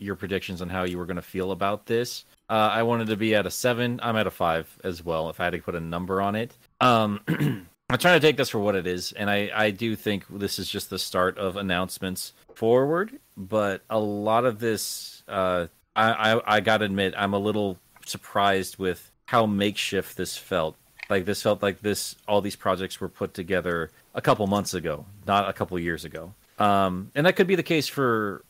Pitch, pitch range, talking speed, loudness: 100 Hz, 95-110 Hz, 220 wpm, -25 LUFS